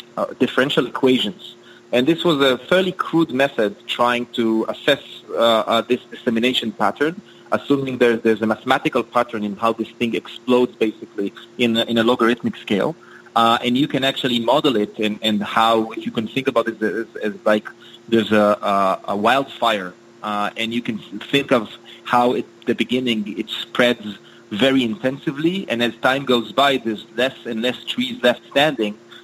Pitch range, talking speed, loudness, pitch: 110-130 Hz, 170 wpm, -19 LUFS, 120 Hz